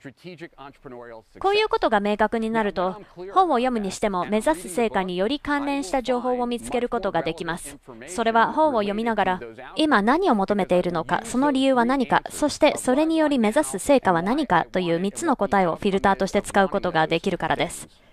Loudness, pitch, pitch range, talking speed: -22 LUFS, 210 Hz, 180-260 Hz, 390 characters per minute